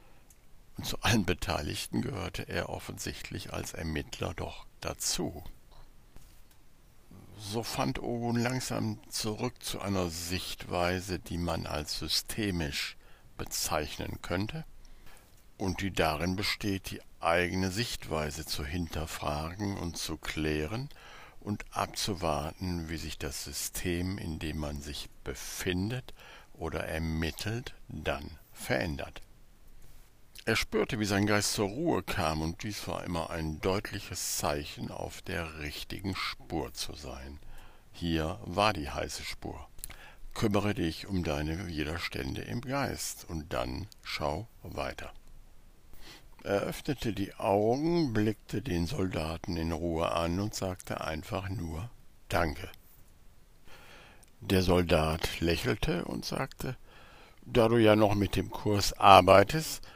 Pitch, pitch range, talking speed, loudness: 90 Hz, 80-105 Hz, 115 wpm, -32 LUFS